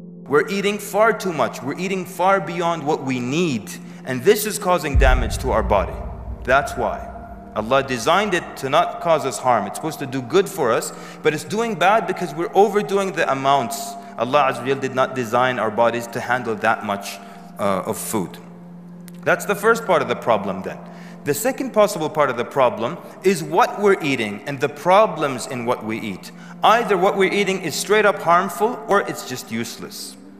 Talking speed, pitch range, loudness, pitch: 195 wpm, 130-200 Hz, -20 LUFS, 175 Hz